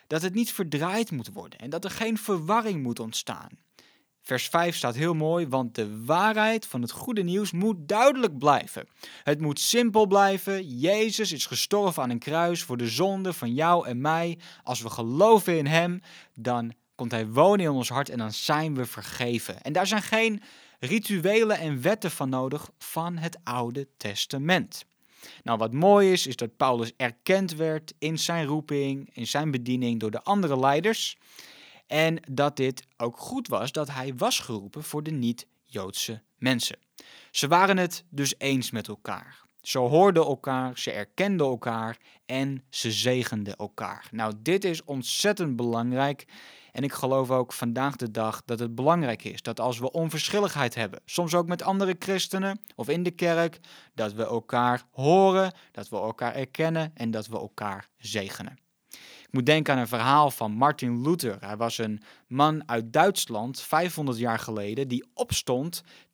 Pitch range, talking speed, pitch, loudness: 120-180 Hz, 170 wpm, 140 Hz, -26 LUFS